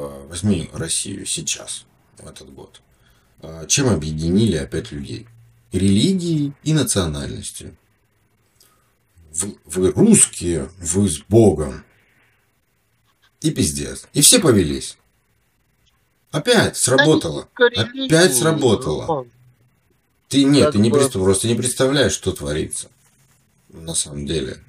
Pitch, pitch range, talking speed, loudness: 110 Hz, 90-130 Hz, 95 wpm, -17 LUFS